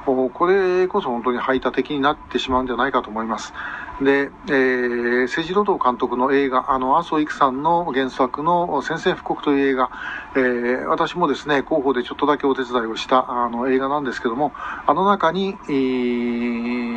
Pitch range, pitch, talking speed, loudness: 125-150 Hz, 135 Hz, 355 characters per minute, -20 LUFS